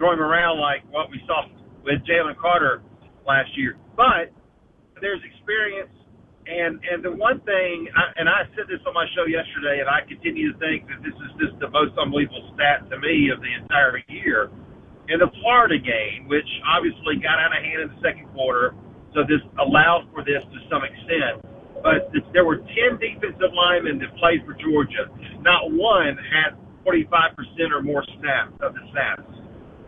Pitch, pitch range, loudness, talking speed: 170 Hz, 150-195 Hz, -21 LUFS, 185 wpm